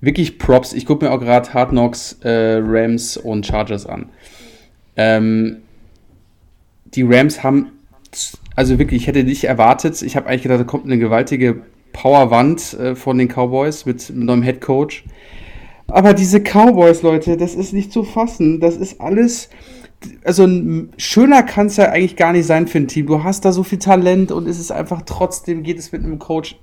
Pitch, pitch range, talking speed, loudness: 140 Hz, 120-175 Hz, 185 wpm, -14 LUFS